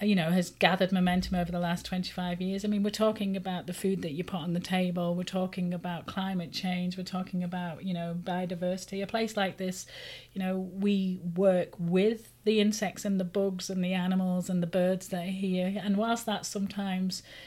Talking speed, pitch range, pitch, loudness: 210 wpm, 180-195 Hz, 185 Hz, -31 LUFS